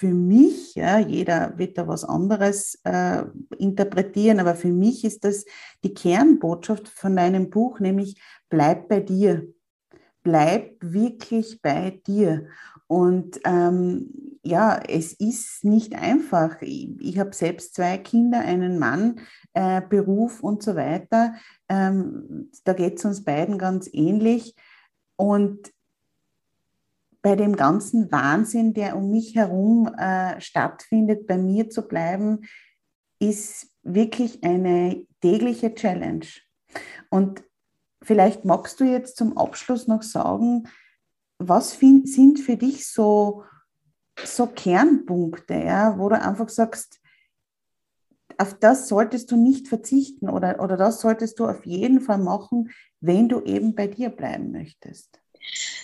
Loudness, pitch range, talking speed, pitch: -21 LUFS, 185-230 Hz, 130 wpm, 210 Hz